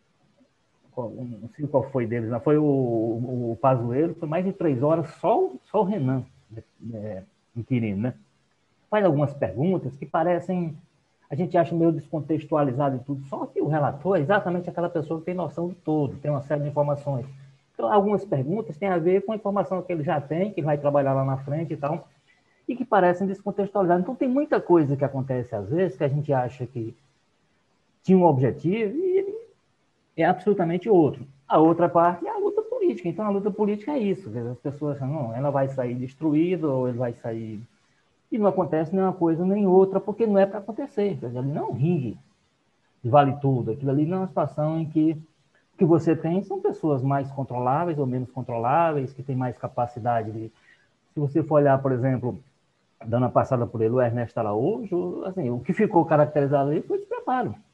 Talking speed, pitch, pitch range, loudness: 195 wpm, 150 Hz, 130-185 Hz, -24 LUFS